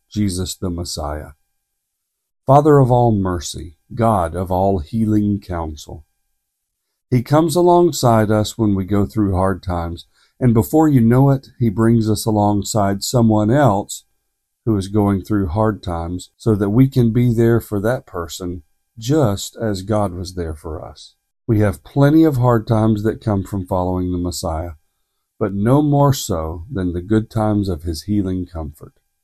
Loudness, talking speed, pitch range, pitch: -17 LUFS, 160 wpm, 90-115 Hz, 105 Hz